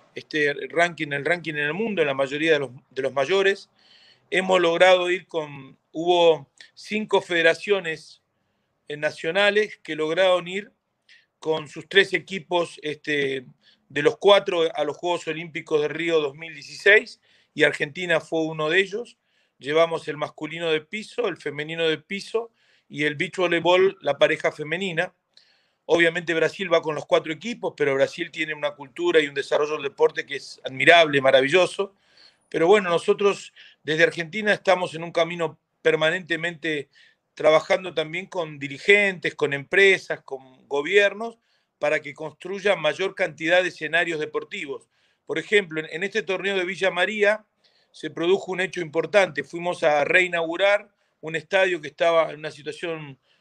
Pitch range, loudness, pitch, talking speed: 155-190 Hz, -22 LUFS, 165 Hz, 150 wpm